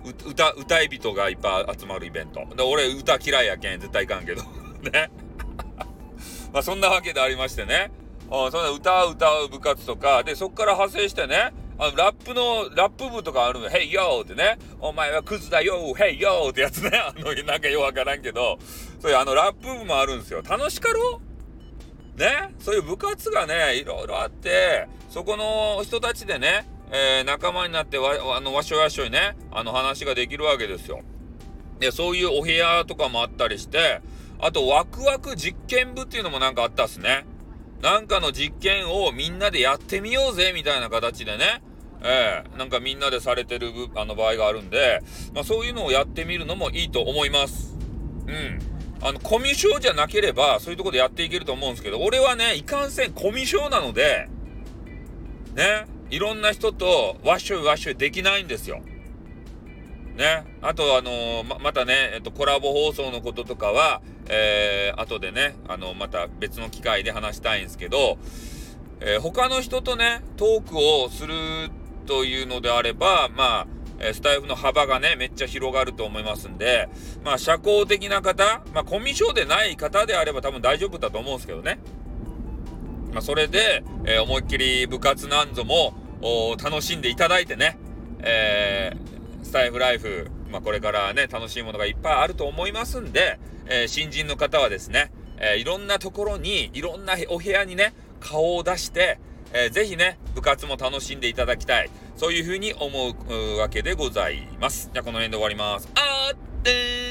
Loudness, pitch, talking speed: -23 LUFS, 150 Hz, 360 characters per minute